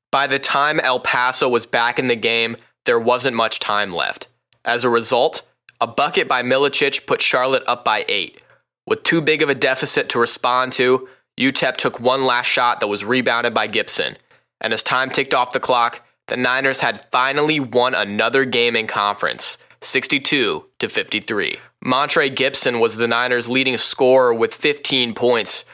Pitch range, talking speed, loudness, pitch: 115-135 Hz, 175 wpm, -17 LUFS, 125 Hz